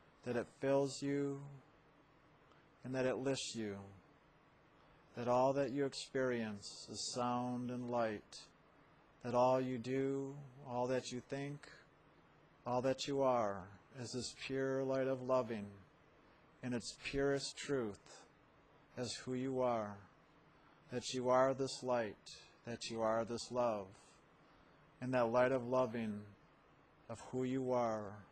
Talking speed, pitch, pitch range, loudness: 135 wpm, 125 Hz, 120-135 Hz, -40 LUFS